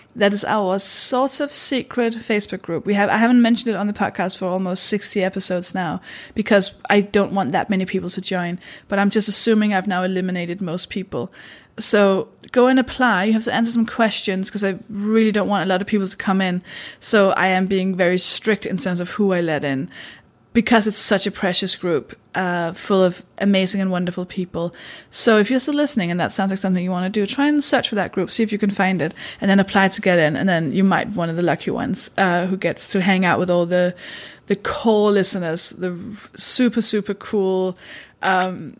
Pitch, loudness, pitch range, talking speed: 195 Hz, -19 LUFS, 185-215 Hz, 225 wpm